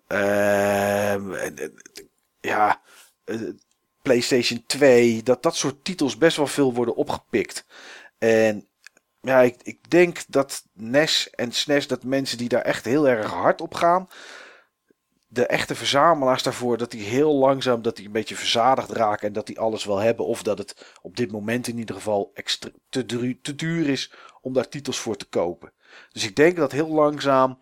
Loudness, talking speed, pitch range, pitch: -22 LUFS, 170 wpm, 110-145 Hz, 125 Hz